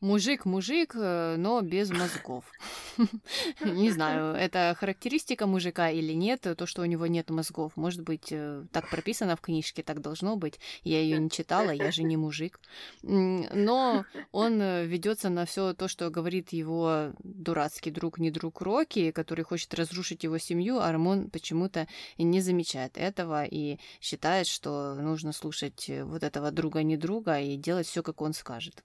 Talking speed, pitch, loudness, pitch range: 155 wpm, 170 Hz, -30 LUFS, 160-190 Hz